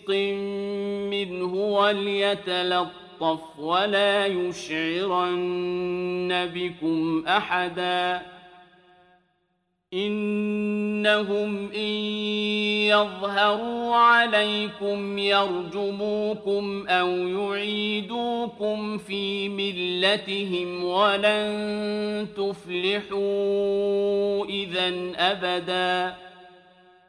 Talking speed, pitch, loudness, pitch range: 40 wpm, 200 Hz, -25 LUFS, 180-210 Hz